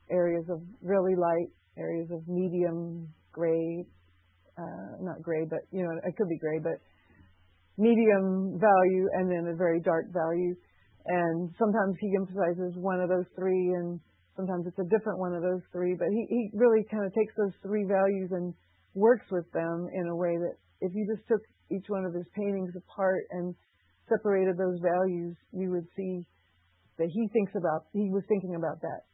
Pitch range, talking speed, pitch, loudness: 170-195 Hz, 180 wpm, 180 Hz, -30 LUFS